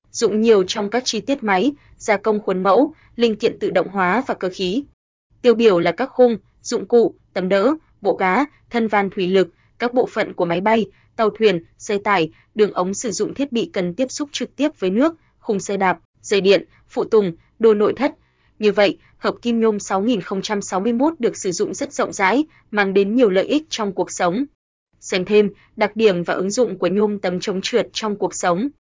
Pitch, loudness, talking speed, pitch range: 215 Hz, -19 LUFS, 210 wpm, 190-245 Hz